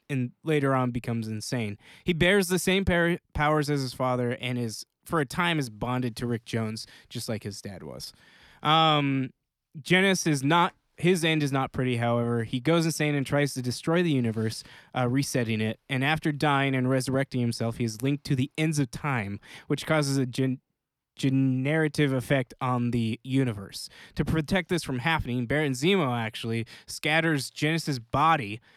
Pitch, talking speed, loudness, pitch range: 135 Hz, 175 wpm, -27 LUFS, 120-155 Hz